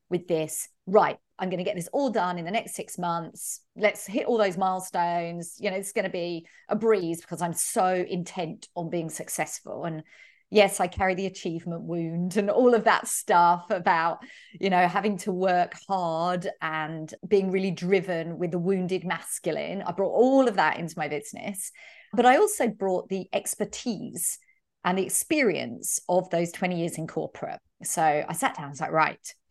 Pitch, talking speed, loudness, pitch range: 185 Hz, 185 wpm, -26 LUFS, 170-205 Hz